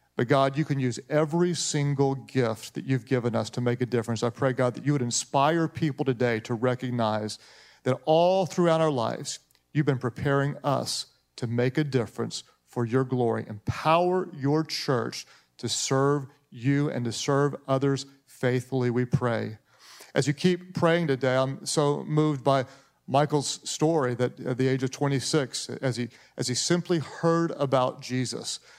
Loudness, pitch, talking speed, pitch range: -27 LUFS, 135 Hz, 170 wpm, 125-150 Hz